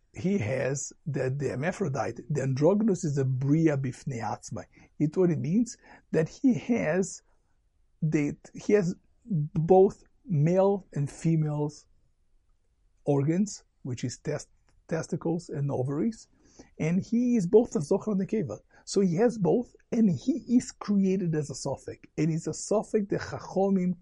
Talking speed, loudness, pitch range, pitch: 145 wpm, -28 LUFS, 140-200 Hz, 165 Hz